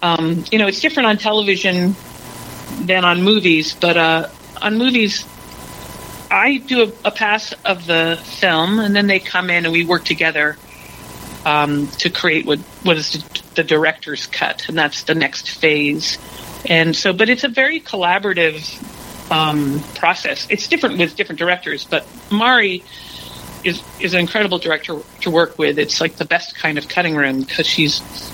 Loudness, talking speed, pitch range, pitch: -16 LUFS, 165 wpm, 160-205 Hz, 170 Hz